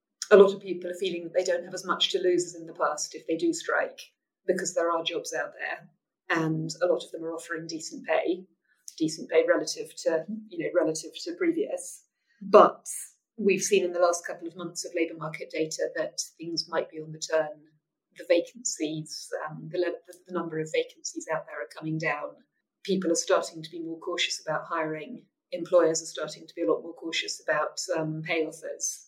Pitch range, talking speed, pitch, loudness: 160-220 Hz, 210 wpm, 175 Hz, -28 LUFS